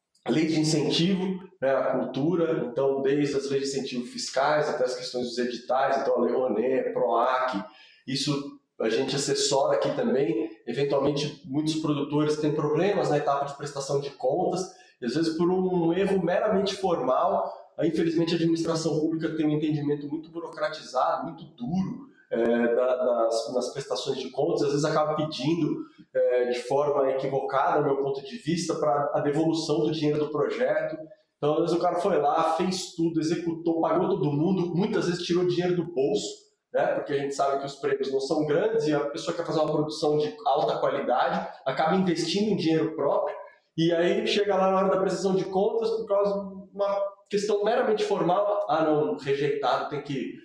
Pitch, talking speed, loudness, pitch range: 160 Hz, 185 wpm, -26 LUFS, 145-190 Hz